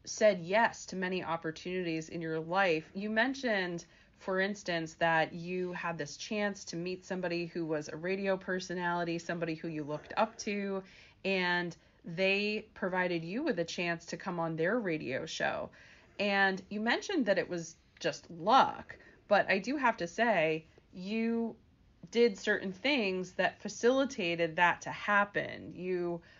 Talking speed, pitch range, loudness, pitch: 155 wpm, 170-205 Hz, -33 LUFS, 185 Hz